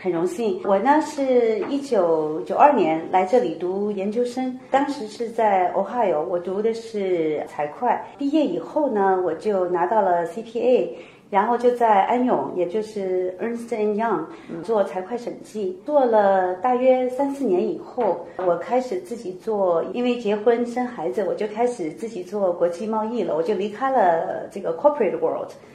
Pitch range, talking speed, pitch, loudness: 185-245 Hz, 295 characters per minute, 215 Hz, -22 LUFS